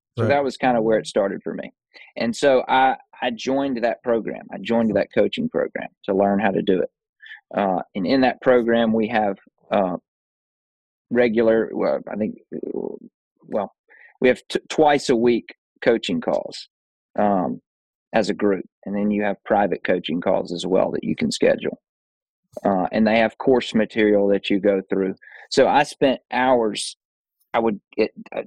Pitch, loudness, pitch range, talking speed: 115 Hz, -21 LUFS, 105-125 Hz, 175 wpm